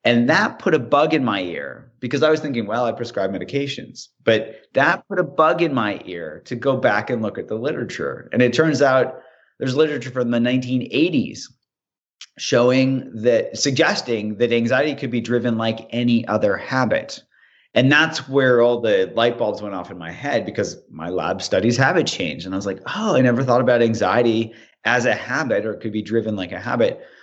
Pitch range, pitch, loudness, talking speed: 115-140 Hz, 120 Hz, -20 LUFS, 205 wpm